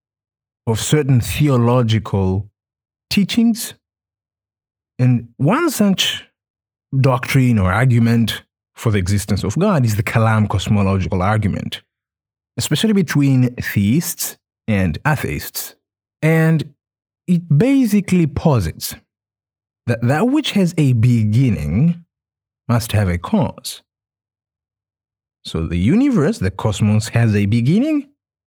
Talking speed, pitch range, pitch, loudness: 100 wpm, 105-145 Hz, 115 Hz, -17 LUFS